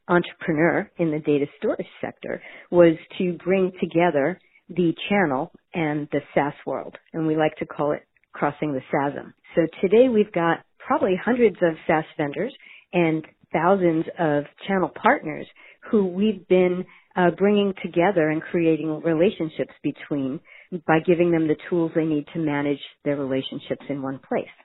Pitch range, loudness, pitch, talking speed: 150-180 Hz, -23 LUFS, 165 Hz, 155 wpm